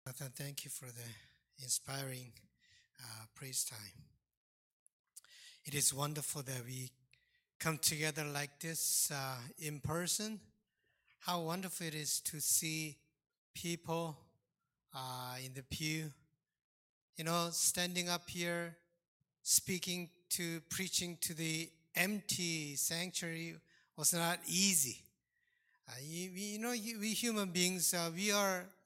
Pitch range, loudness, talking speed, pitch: 140-175 Hz, -37 LUFS, 120 wpm, 160 Hz